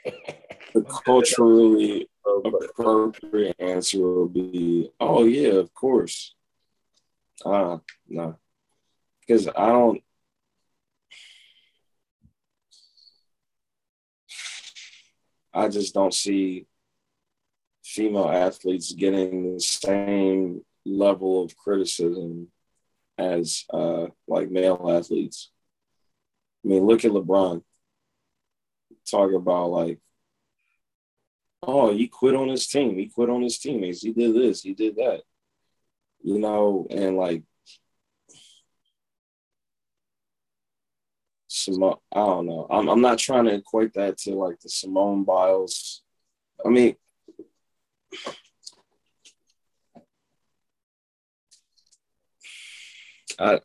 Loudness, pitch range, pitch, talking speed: -23 LUFS, 90-115 Hz, 100 Hz, 90 wpm